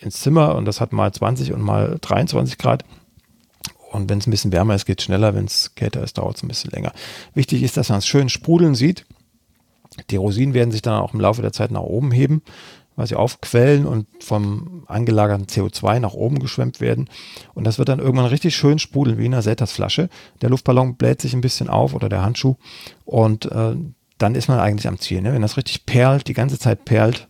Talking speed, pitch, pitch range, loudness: 225 wpm, 120 Hz, 105-135 Hz, -19 LUFS